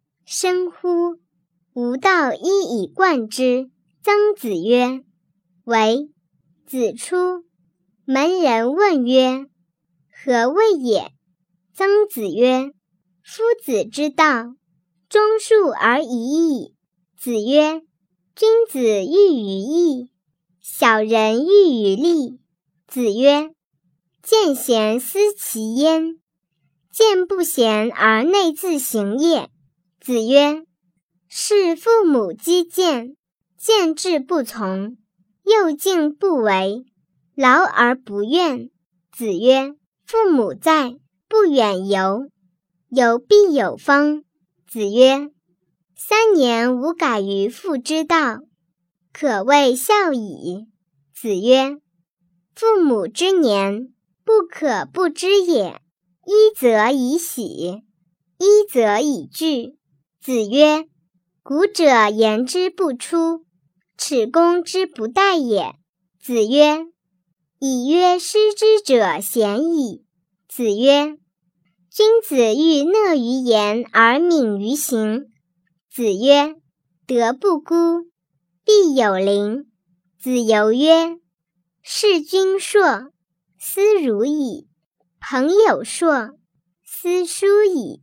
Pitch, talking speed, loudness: 250 Hz, 125 characters per minute, -17 LUFS